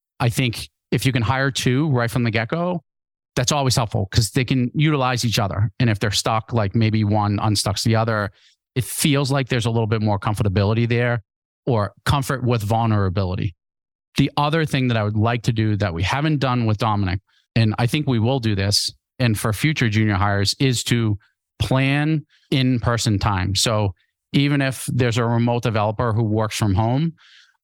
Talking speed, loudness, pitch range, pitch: 195 wpm, -20 LUFS, 105-135 Hz, 120 Hz